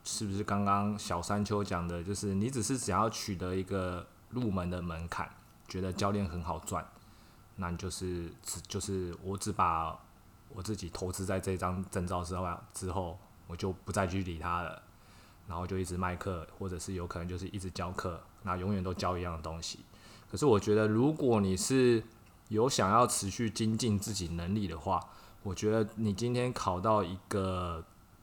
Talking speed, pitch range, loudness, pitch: 270 characters per minute, 90-105 Hz, -34 LUFS, 95 Hz